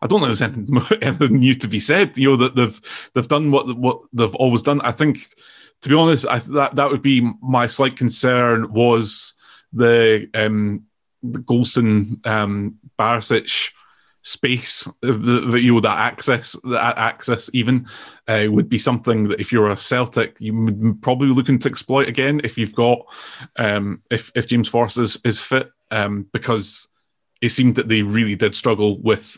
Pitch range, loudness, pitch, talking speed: 110-130 Hz, -18 LUFS, 120 Hz, 180 wpm